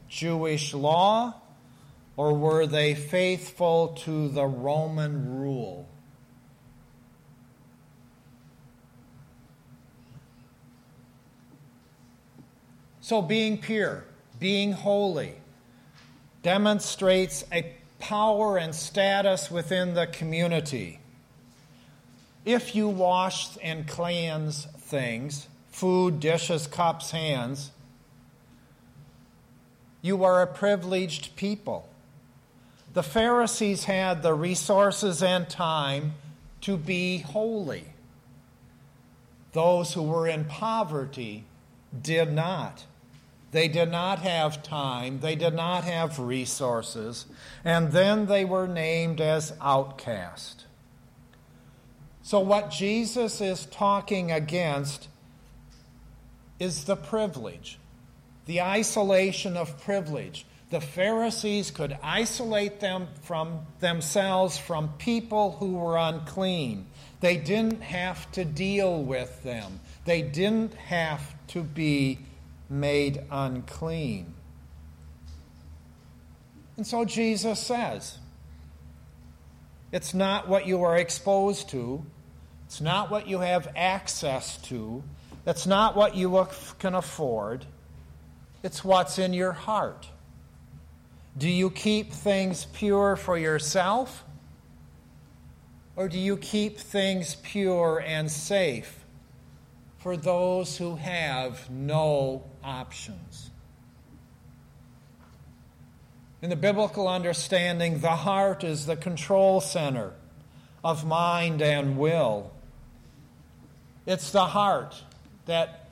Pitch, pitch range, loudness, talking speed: 165 Hz, 140-190 Hz, -27 LUFS, 95 wpm